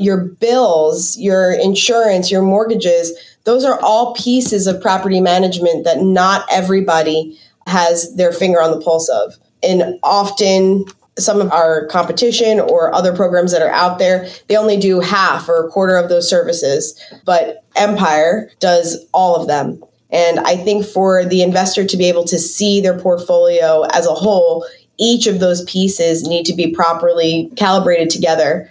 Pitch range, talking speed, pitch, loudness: 170-200 Hz, 165 wpm, 185 Hz, -13 LUFS